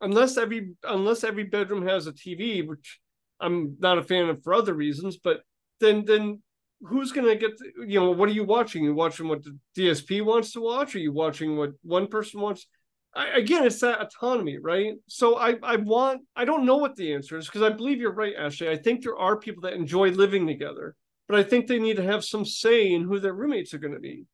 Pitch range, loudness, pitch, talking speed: 175-230 Hz, -25 LUFS, 210 Hz, 230 wpm